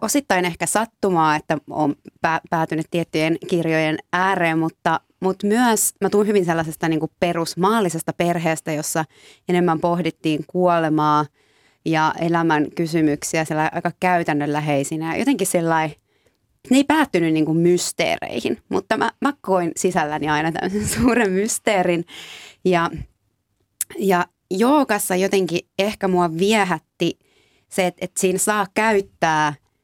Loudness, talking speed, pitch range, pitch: -20 LUFS, 115 wpm, 160-190 Hz, 170 Hz